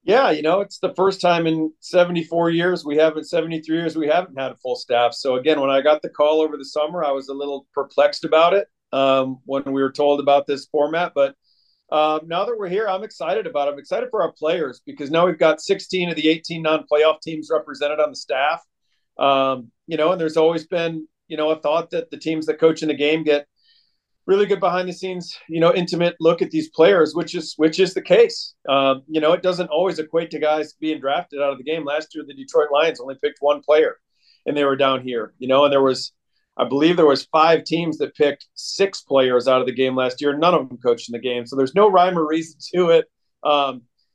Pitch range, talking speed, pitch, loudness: 140-170 Hz, 240 wpm, 155 Hz, -20 LUFS